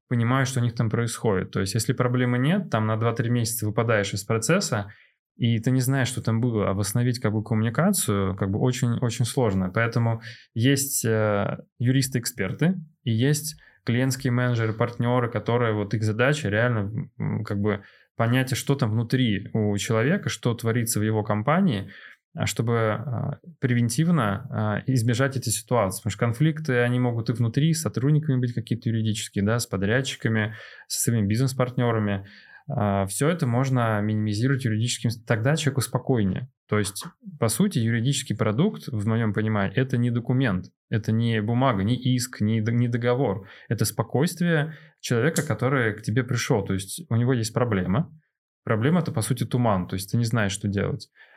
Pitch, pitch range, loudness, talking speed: 120 Hz, 110-130 Hz, -24 LUFS, 160 wpm